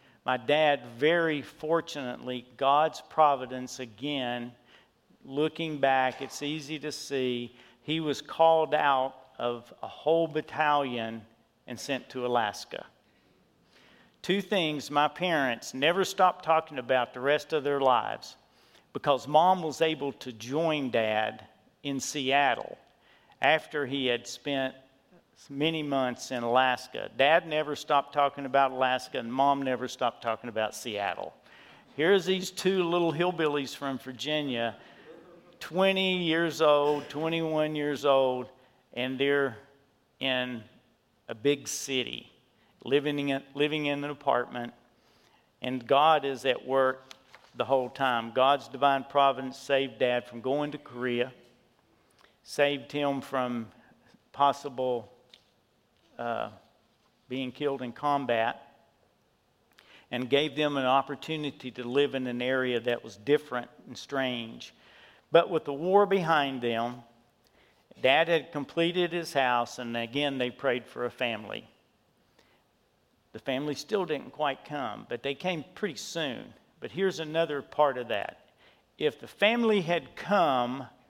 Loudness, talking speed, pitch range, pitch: -29 LUFS, 130 wpm, 125-150 Hz, 140 Hz